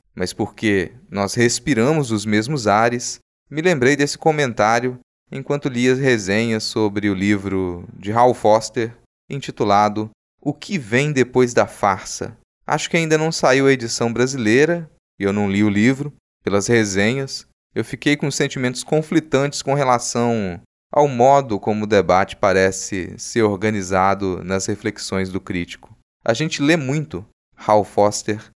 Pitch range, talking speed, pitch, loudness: 105-140 Hz, 145 wpm, 115 Hz, -19 LUFS